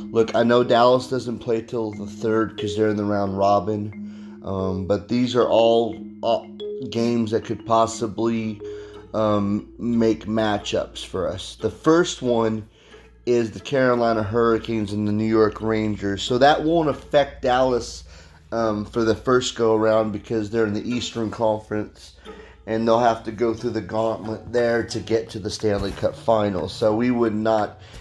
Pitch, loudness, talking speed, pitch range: 110 Hz, -22 LUFS, 170 wpm, 105-115 Hz